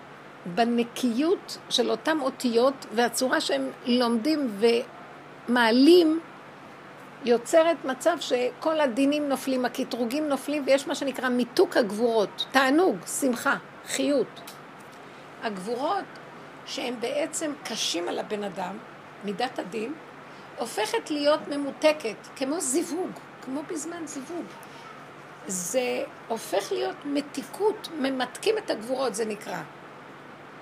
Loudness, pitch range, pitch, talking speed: -26 LUFS, 240-310 Hz, 270 Hz, 95 wpm